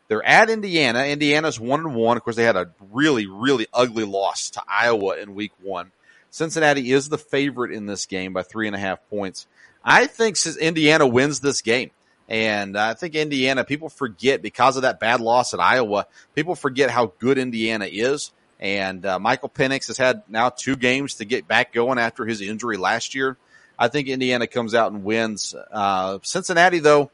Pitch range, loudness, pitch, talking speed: 110-145 Hz, -20 LUFS, 125 Hz, 190 wpm